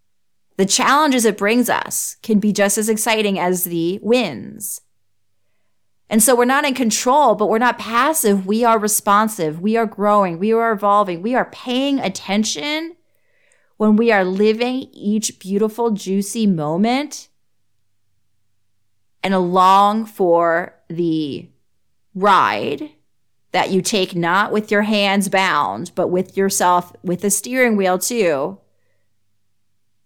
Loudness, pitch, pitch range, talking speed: -17 LUFS, 200 Hz, 170-225 Hz, 130 wpm